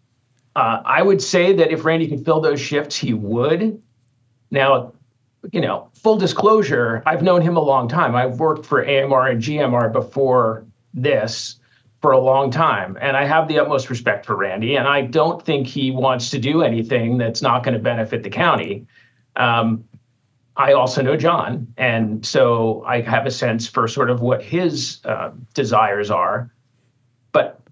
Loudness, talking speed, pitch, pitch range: -18 LUFS, 170 wpm, 130 Hz, 120-150 Hz